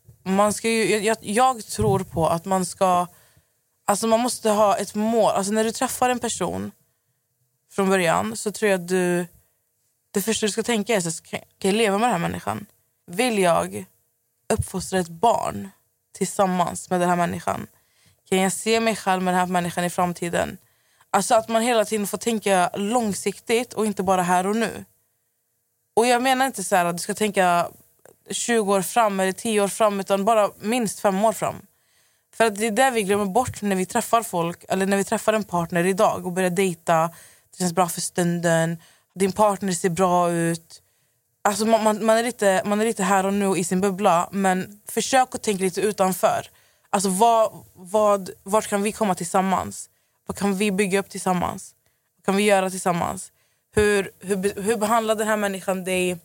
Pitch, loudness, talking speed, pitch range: 195 Hz, -22 LUFS, 190 wpm, 180-220 Hz